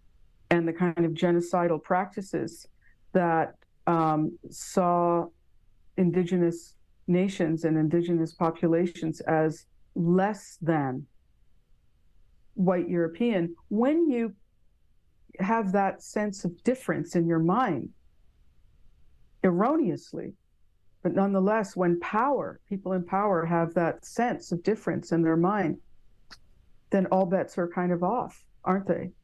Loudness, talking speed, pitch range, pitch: -27 LUFS, 110 wpm, 170-195 Hz, 180 Hz